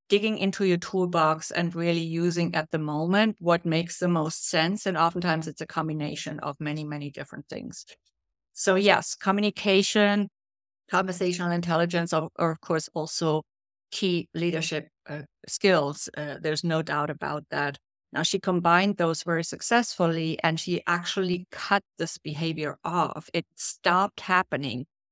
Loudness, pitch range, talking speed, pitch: -26 LUFS, 155-180 Hz, 145 wpm, 165 Hz